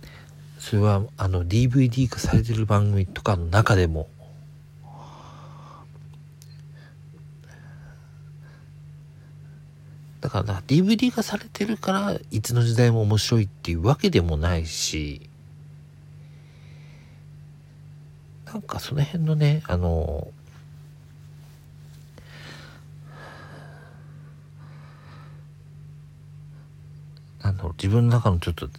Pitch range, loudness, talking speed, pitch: 115-145 Hz, -23 LUFS, 165 characters per minute, 145 Hz